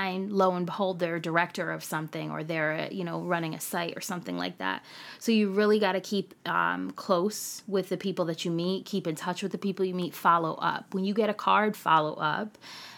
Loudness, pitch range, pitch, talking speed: -29 LUFS, 160-195 Hz, 180 Hz, 230 wpm